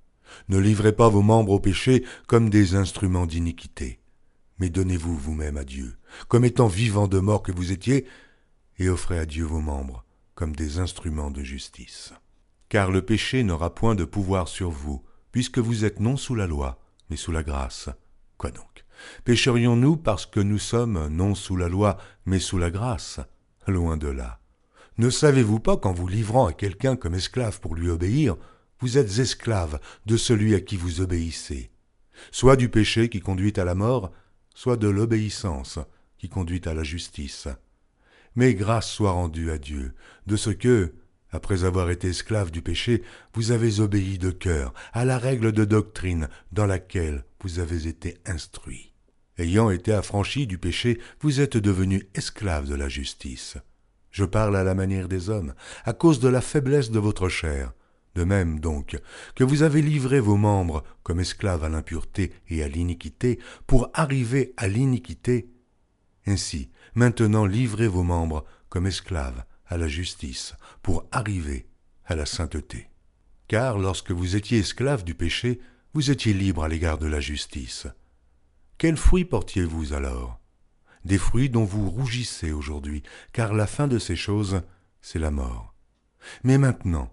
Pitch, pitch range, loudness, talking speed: 95 Hz, 80-115 Hz, -24 LUFS, 165 wpm